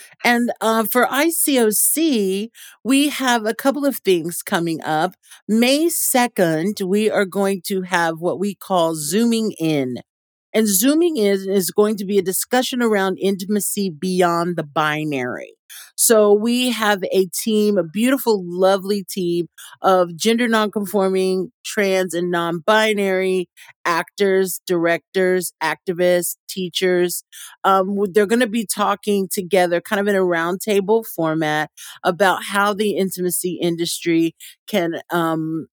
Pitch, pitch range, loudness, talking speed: 195 Hz, 175-215 Hz, -19 LUFS, 130 wpm